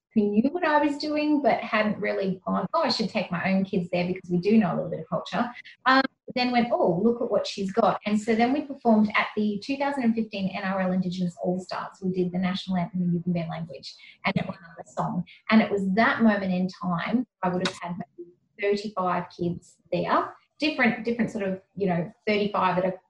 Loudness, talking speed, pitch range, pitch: -26 LUFS, 215 wpm, 180-225 Hz, 195 Hz